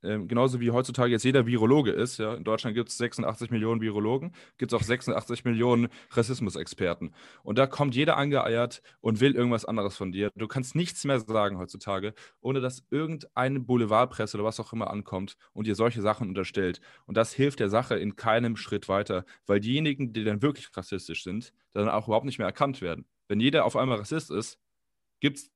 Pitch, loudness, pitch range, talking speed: 115 Hz, -28 LUFS, 105-130 Hz, 195 wpm